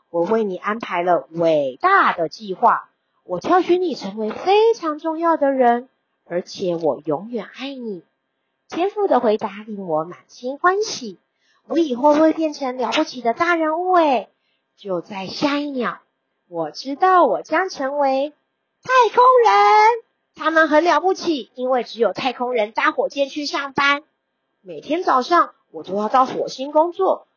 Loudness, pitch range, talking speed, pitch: -19 LUFS, 215-330 Hz, 220 characters per minute, 275 Hz